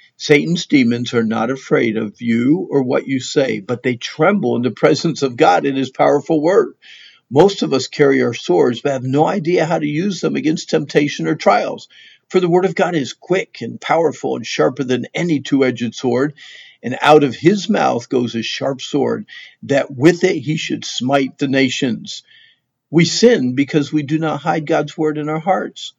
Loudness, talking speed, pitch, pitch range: -16 LUFS, 195 wpm, 150 Hz, 130-165 Hz